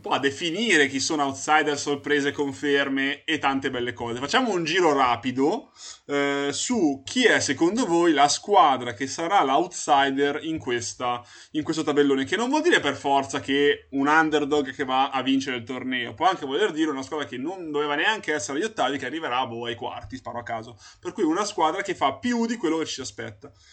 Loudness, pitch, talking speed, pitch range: -24 LUFS, 140 Hz, 200 wpm, 130-155 Hz